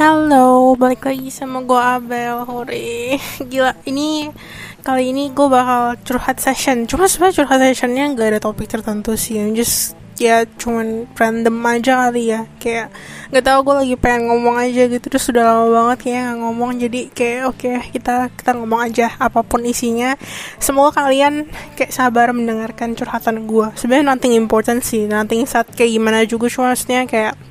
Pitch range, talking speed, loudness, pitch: 230-260 Hz, 165 wpm, -15 LUFS, 245 Hz